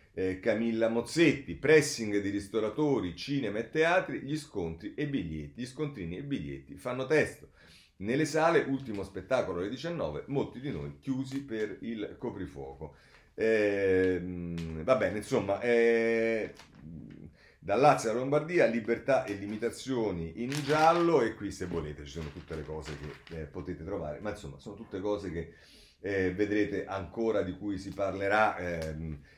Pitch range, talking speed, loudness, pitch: 85-120 Hz, 150 wpm, -31 LUFS, 100 Hz